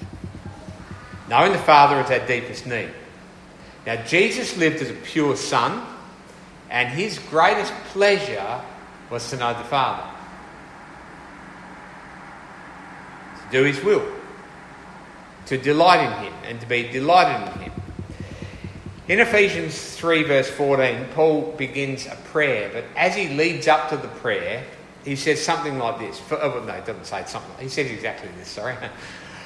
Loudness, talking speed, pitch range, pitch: -21 LUFS, 145 wpm, 120-165 Hz, 140 Hz